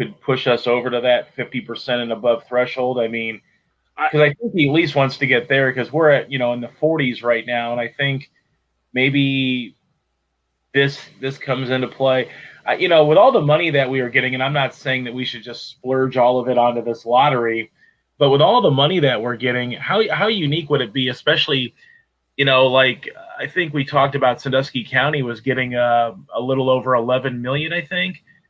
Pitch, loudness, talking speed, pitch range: 130 Hz, -18 LUFS, 215 wpm, 120-140 Hz